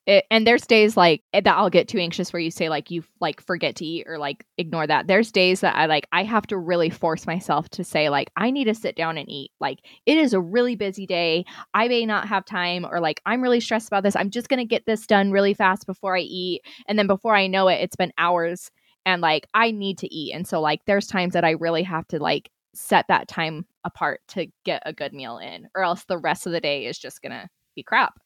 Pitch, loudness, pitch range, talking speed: 185 Hz, -22 LUFS, 170-205 Hz, 265 wpm